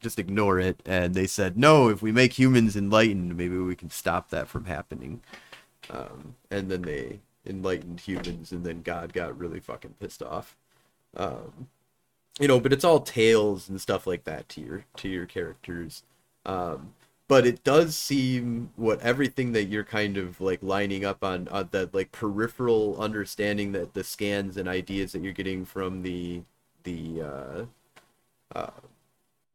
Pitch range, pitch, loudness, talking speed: 90-110 Hz, 100 Hz, -26 LUFS, 165 wpm